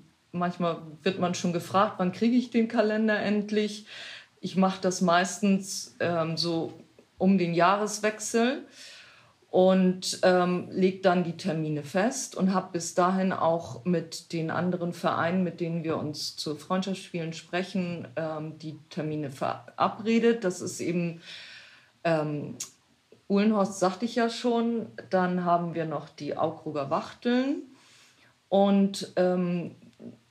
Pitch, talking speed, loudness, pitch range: 180 Hz, 130 wpm, -28 LUFS, 165-200 Hz